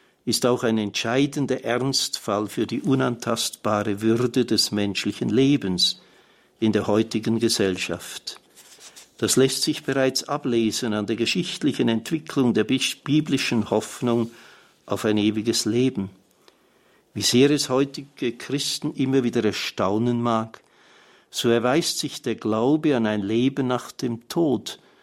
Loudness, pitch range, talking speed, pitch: -23 LUFS, 110-135 Hz, 125 wpm, 115 Hz